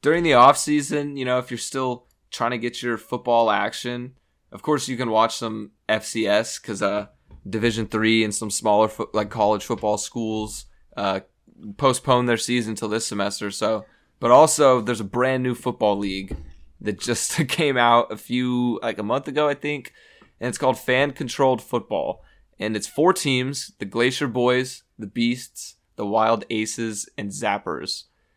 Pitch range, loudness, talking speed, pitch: 105-125 Hz, -22 LUFS, 175 wpm, 120 Hz